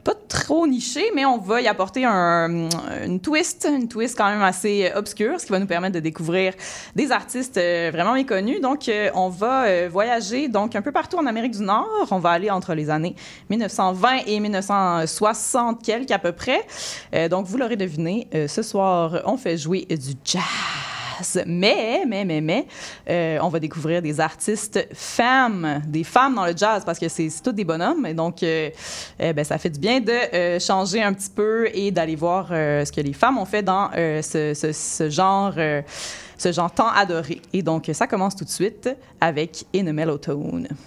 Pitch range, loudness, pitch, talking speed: 165-225 Hz, -22 LUFS, 190 Hz, 195 wpm